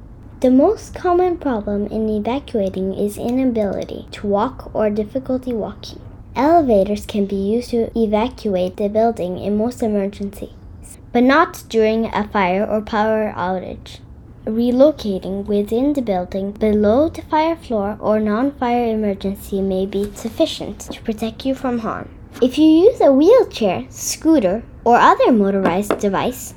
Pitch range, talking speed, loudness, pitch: 205-255 Hz, 140 wpm, -18 LUFS, 220 Hz